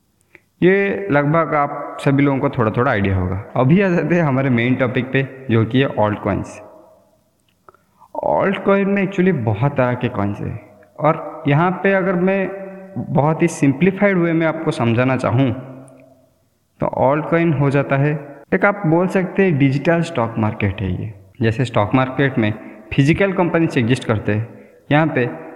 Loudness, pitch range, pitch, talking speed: -17 LUFS, 115-165 Hz, 140 Hz, 170 wpm